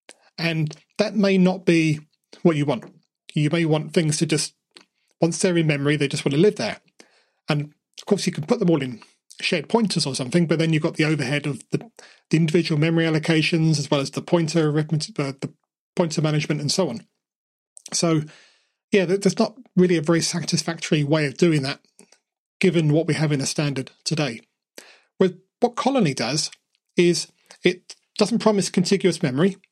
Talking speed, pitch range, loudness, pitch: 185 wpm, 150-185 Hz, -22 LUFS, 165 Hz